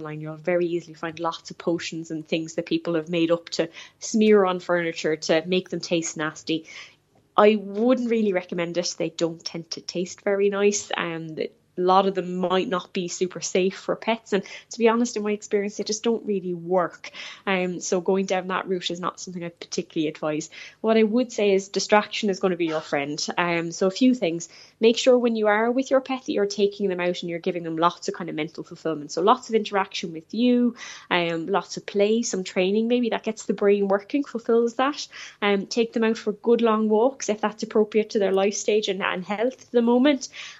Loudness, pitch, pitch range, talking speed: -24 LUFS, 195 Hz, 170-220 Hz, 230 wpm